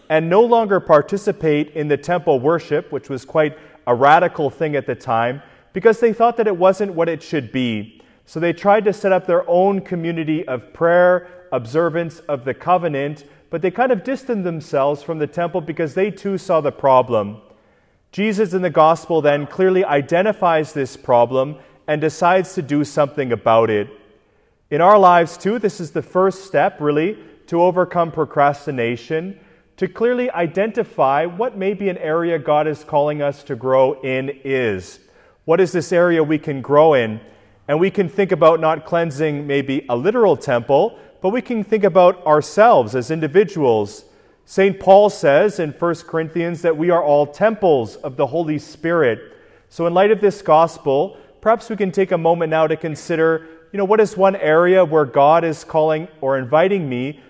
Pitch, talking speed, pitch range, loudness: 165 Hz, 180 wpm, 145-185 Hz, -17 LUFS